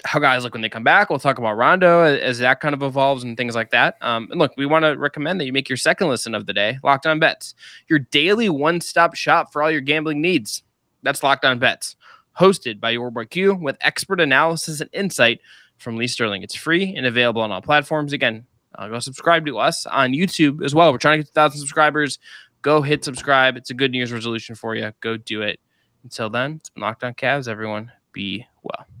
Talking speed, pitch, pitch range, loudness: 230 wpm, 140 Hz, 120-155 Hz, -19 LUFS